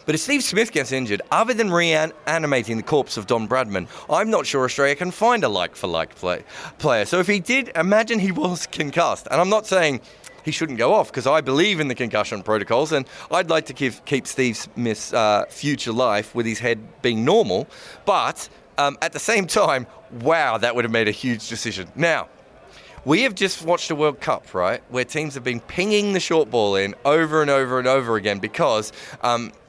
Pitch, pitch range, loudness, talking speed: 140 Hz, 120-175 Hz, -21 LUFS, 210 wpm